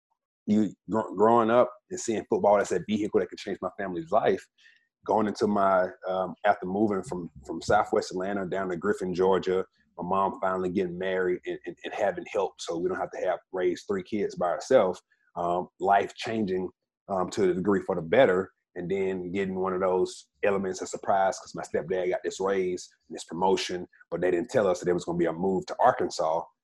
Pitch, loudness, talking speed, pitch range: 95 Hz, -28 LUFS, 210 wpm, 95-115 Hz